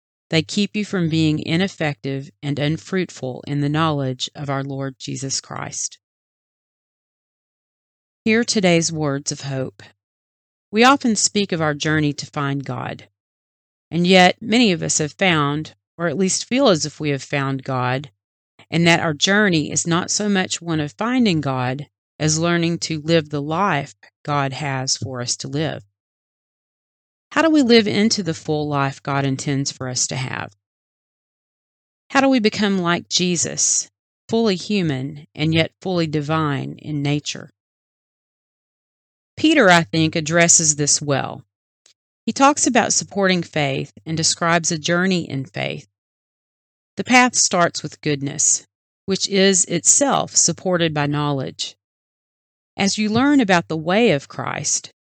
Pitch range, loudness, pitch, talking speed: 135-185 Hz, -19 LUFS, 155 Hz, 145 wpm